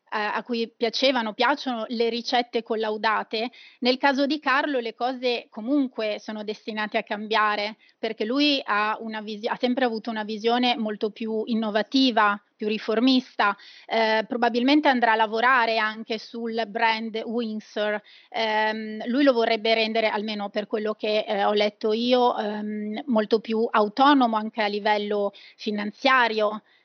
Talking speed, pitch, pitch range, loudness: 140 wpm, 225 Hz, 215-245 Hz, -24 LUFS